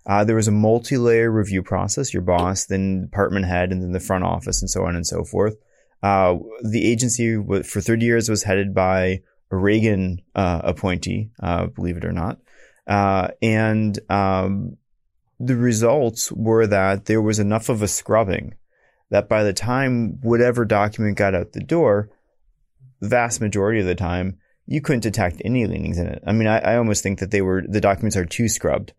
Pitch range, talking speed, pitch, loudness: 95-115 Hz, 190 wpm, 105 Hz, -20 LUFS